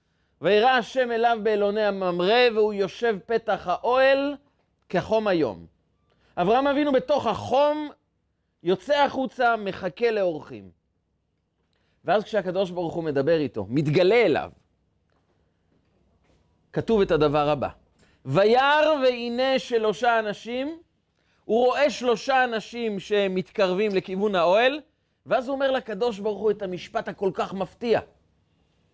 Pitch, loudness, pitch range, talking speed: 205 Hz, -23 LUFS, 145-240 Hz, 110 wpm